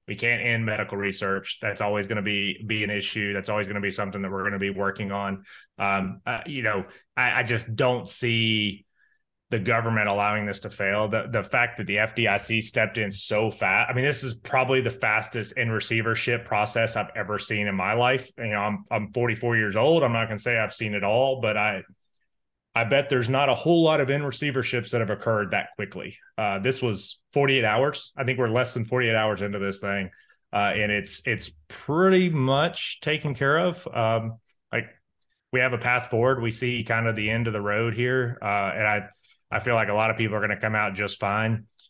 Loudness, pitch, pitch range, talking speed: -25 LUFS, 110 Hz, 105-125 Hz, 225 wpm